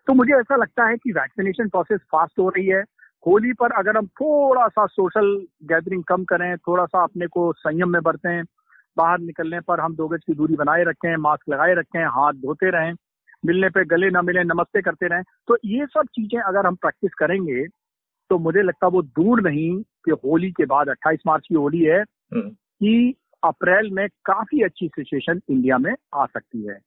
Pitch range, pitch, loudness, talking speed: 165-210 Hz, 180 Hz, -20 LUFS, 195 wpm